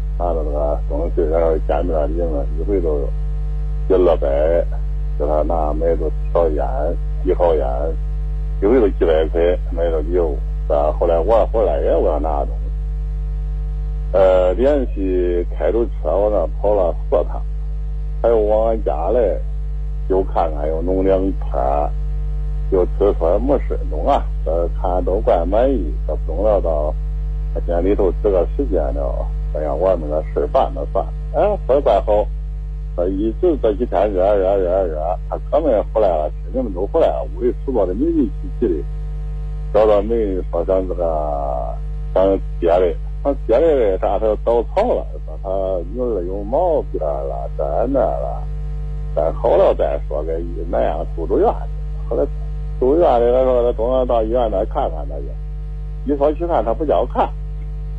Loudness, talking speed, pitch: -19 LUFS, 225 characters per minute, 90 Hz